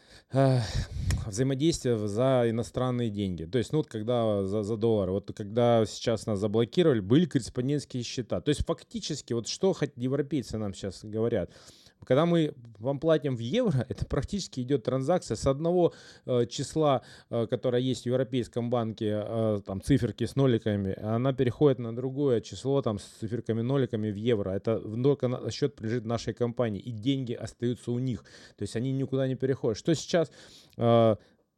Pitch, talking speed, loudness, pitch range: 120 Hz, 165 wpm, -29 LUFS, 110-135 Hz